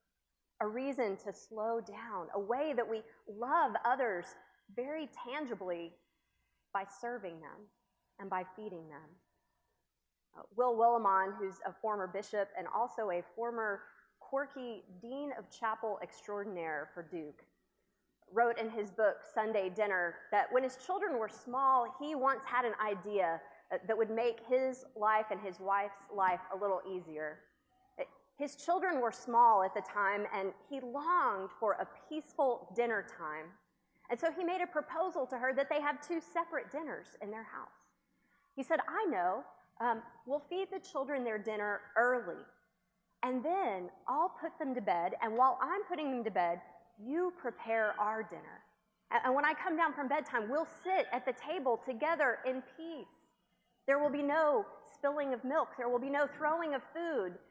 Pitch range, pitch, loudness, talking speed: 200-285 Hz, 235 Hz, -36 LUFS, 165 wpm